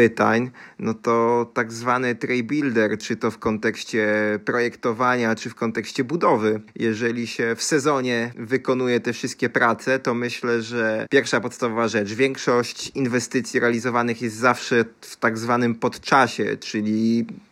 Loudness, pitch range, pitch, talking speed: -22 LUFS, 115-125 Hz, 120 Hz, 135 wpm